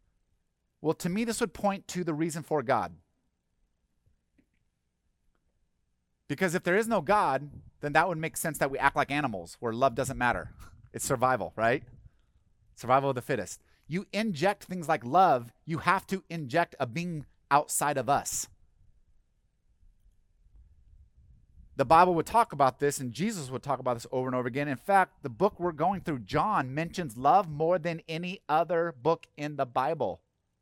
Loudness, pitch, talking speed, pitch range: -29 LUFS, 140 Hz, 170 wpm, 105-170 Hz